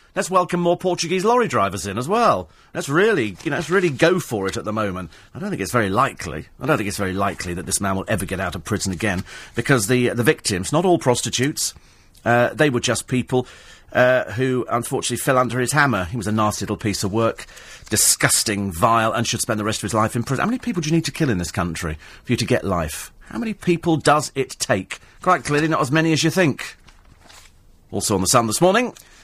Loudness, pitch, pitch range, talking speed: -20 LUFS, 120 Hz, 100-150 Hz, 240 wpm